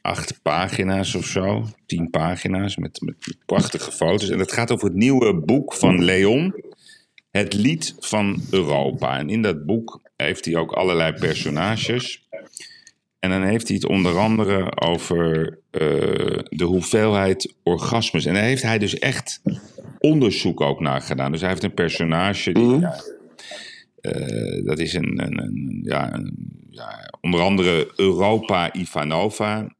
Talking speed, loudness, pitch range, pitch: 145 wpm, -21 LUFS, 90-110 Hz, 95 Hz